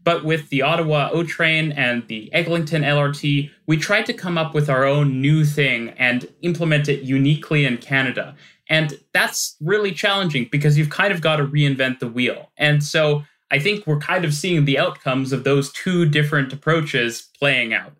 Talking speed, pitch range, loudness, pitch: 185 wpm, 135-160 Hz, -19 LUFS, 150 Hz